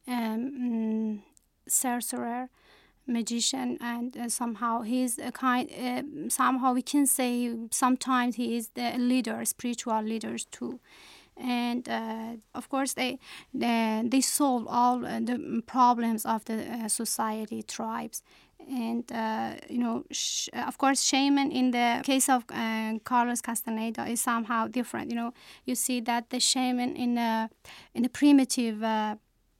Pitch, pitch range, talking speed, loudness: 245 Hz, 230-255 Hz, 140 wpm, -28 LUFS